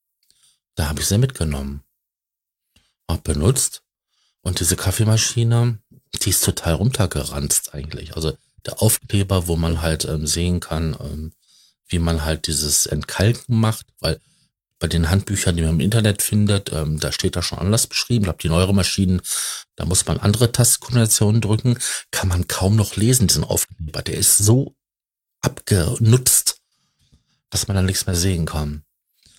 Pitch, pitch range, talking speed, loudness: 95 Hz, 80-110 Hz, 155 wpm, -19 LUFS